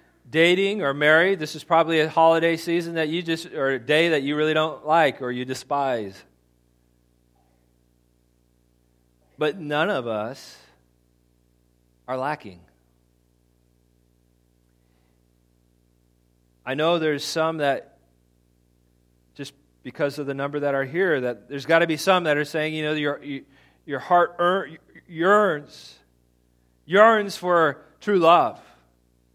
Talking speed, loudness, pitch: 125 wpm, -22 LUFS, 130 Hz